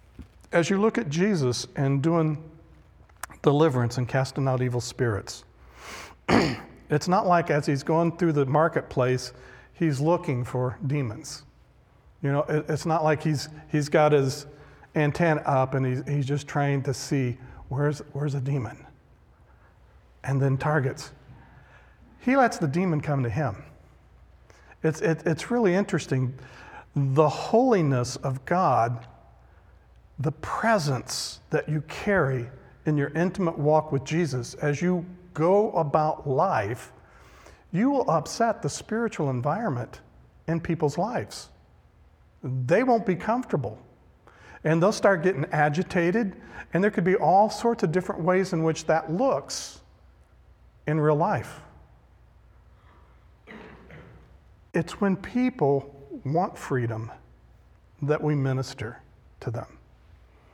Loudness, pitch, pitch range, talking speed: -25 LUFS, 150 Hz, 130-170 Hz, 125 wpm